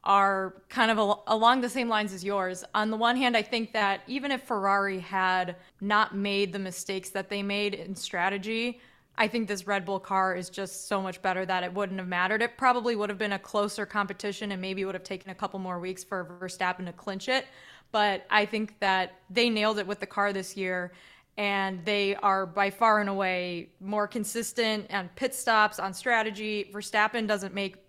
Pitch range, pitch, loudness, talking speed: 190-215 Hz, 200 Hz, -28 LUFS, 210 wpm